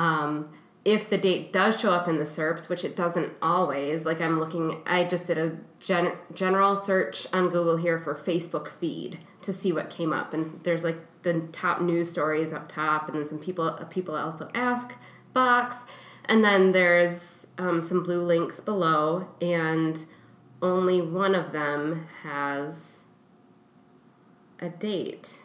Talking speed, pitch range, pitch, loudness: 160 wpm, 160-185 Hz, 170 Hz, -26 LUFS